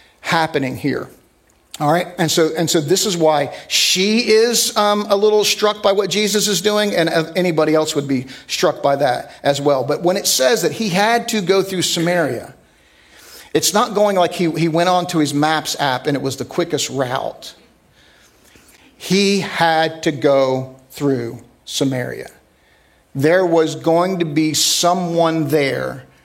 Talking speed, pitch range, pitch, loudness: 170 wpm, 145-190 Hz, 165 Hz, -16 LUFS